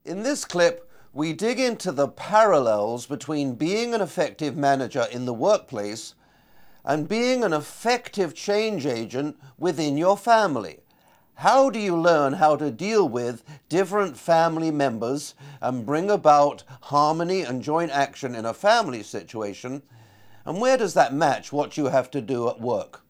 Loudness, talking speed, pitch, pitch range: -23 LUFS, 155 wpm, 150 Hz, 135-190 Hz